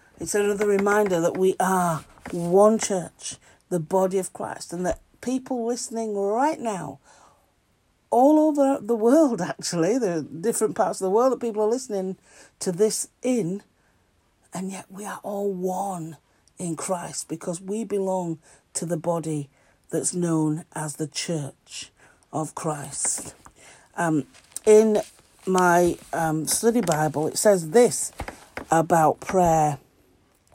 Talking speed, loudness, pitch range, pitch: 135 wpm, -24 LUFS, 160-210 Hz, 180 Hz